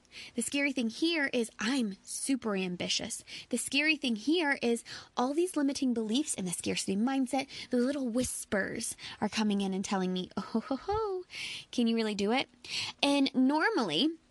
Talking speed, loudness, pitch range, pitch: 170 wpm, -31 LUFS, 215-280 Hz, 250 Hz